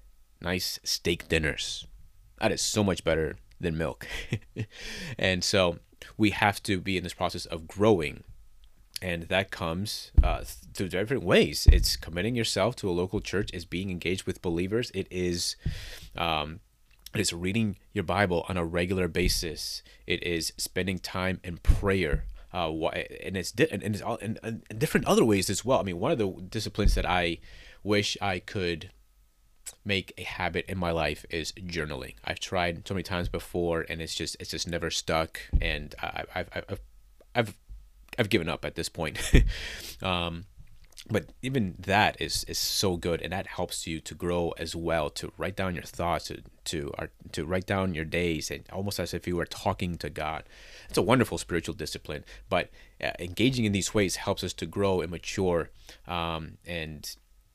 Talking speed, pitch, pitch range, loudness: 175 wpm, 90 Hz, 85-100 Hz, -29 LUFS